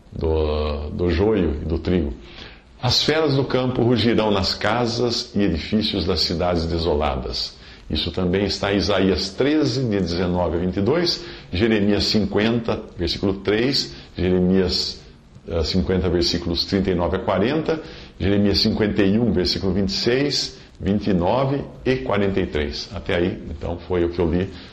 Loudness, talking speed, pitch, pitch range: -21 LUFS, 130 wpm, 95 Hz, 85-110 Hz